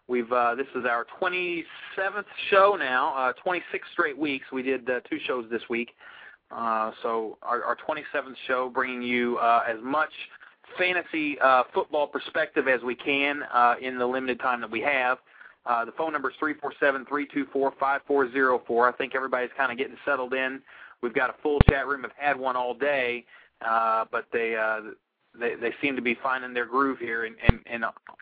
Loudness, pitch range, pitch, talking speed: -26 LUFS, 120-140 Hz, 130 Hz, 210 wpm